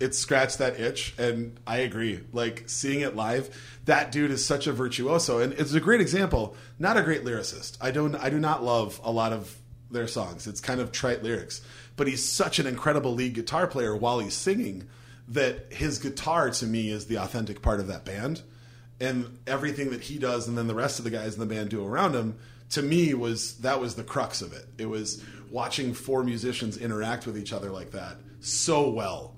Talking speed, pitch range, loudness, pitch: 215 wpm, 115-135 Hz, -28 LUFS, 120 Hz